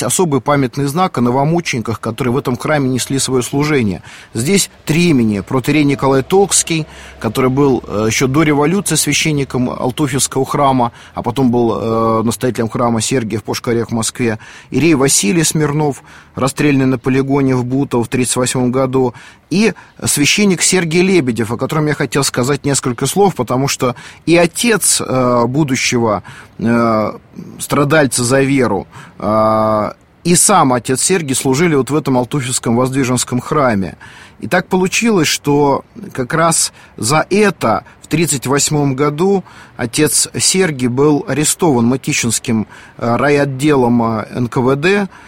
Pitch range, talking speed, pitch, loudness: 120-150 Hz, 125 wpm, 135 Hz, -14 LUFS